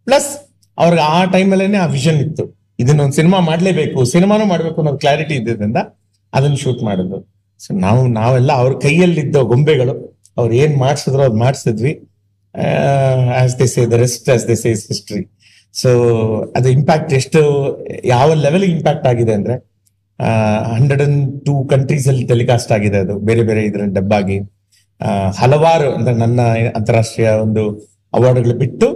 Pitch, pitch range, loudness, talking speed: 125 Hz, 110-145 Hz, -14 LUFS, 120 wpm